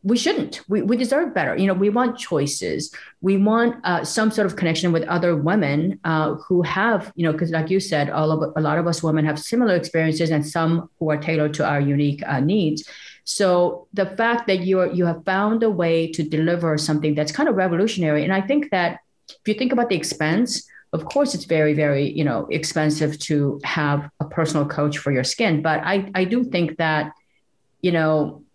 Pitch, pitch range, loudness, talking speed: 165 Hz, 155-195 Hz, -21 LUFS, 210 wpm